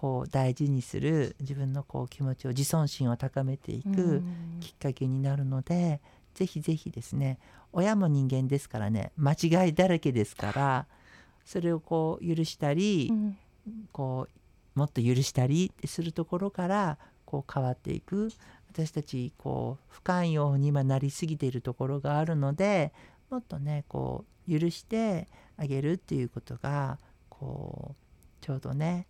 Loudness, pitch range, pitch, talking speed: -30 LUFS, 135-170 Hz, 145 Hz, 295 characters per minute